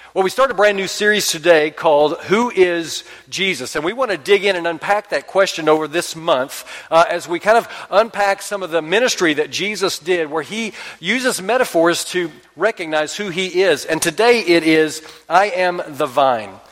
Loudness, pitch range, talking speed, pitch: -17 LUFS, 160-205 Hz, 195 wpm, 180 Hz